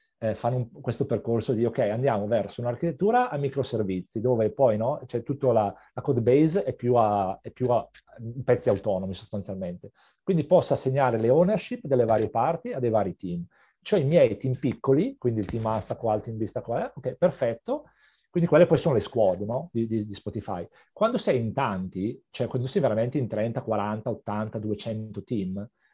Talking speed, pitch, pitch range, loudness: 190 wpm, 120 Hz, 110-135 Hz, -26 LUFS